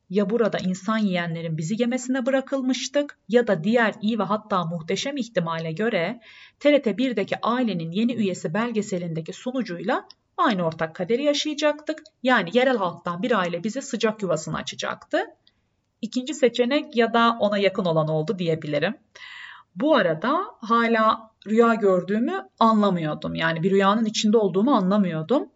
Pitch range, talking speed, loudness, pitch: 185-250 Hz, 135 wpm, -23 LUFS, 220 Hz